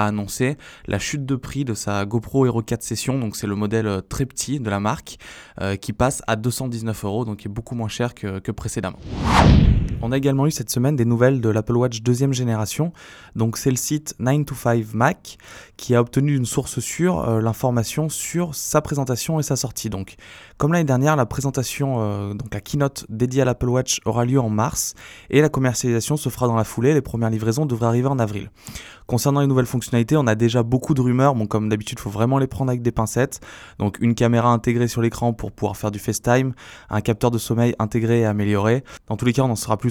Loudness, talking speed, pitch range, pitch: -21 LUFS, 225 wpm, 110-135 Hz, 120 Hz